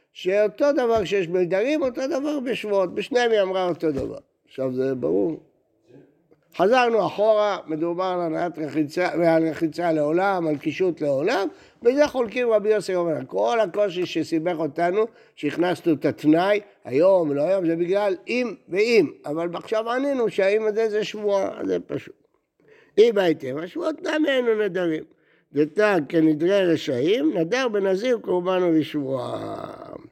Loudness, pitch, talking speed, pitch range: -22 LUFS, 190 Hz, 135 wpm, 165-225 Hz